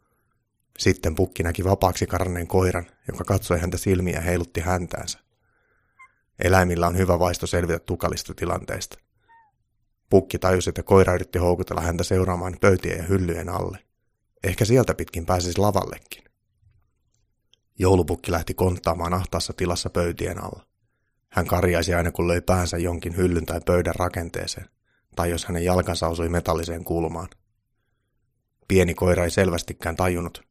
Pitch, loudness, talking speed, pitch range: 90 Hz, -23 LUFS, 130 wpm, 85-100 Hz